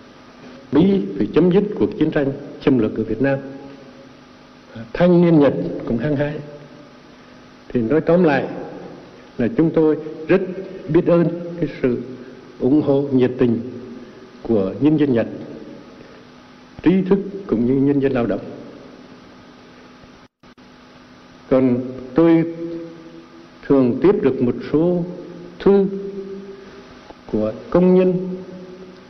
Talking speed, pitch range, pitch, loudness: 120 wpm, 125-175 Hz, 145 Hz, -18 LUFS